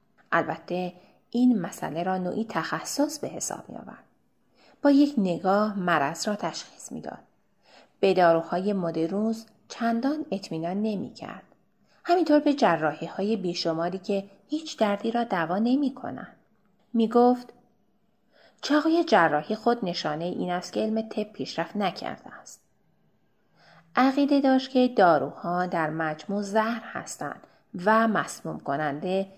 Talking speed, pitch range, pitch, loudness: 120 wpm, 175-240 Hz, 210 Hz, -26 LUFS